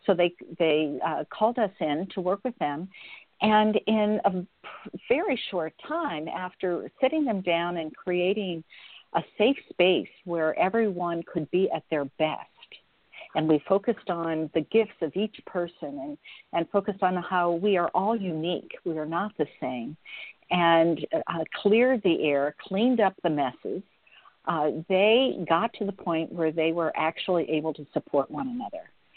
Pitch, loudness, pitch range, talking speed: 180 Hz, -27 LUFS, 160-210 Hz, 165 wpm